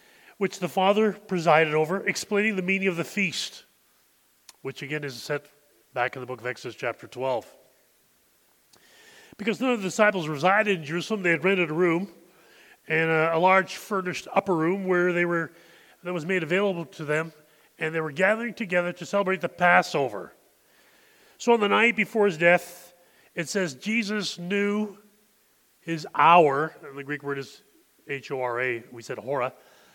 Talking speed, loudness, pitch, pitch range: 170 wpm, -25 LUFS, 175 Hz, 155-200 Hz